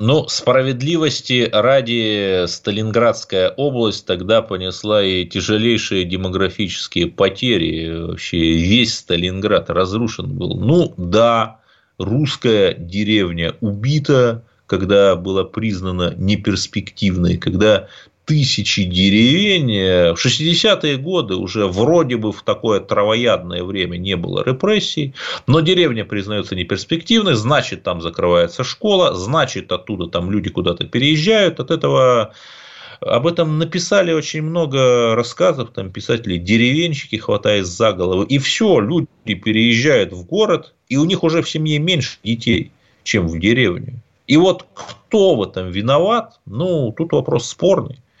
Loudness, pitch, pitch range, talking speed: -16 LUFS, 115 Hz, 95-150 Hz, 120 wpm